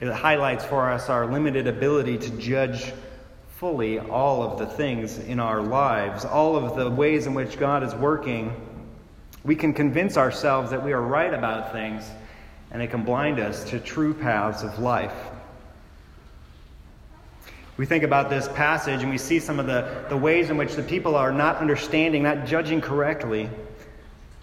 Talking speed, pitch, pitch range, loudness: 170 wpm, 130 Hz, 110-150 Hz, -24 LUFS